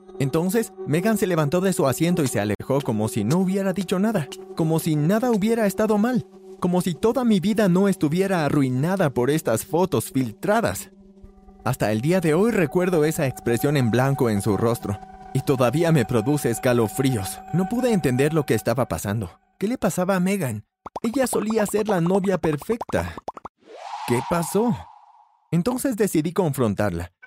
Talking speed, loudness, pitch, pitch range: 165 wpm, -22 LUFS, 175 Hz, 130-195 Hz